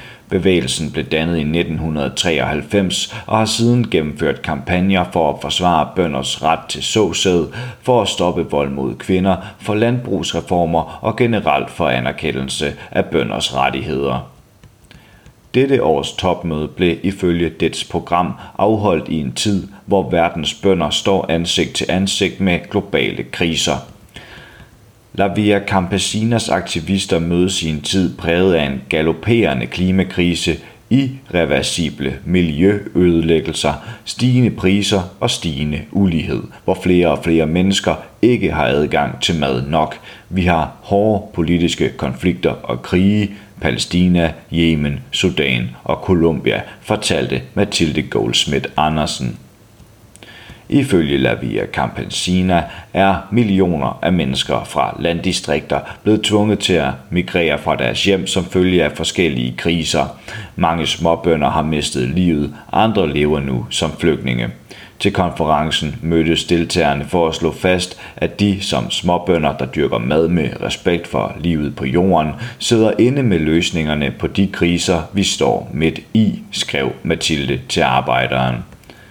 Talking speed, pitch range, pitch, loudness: 125 wpm, 75-100 Hz, 85 Hz, -17 LUFS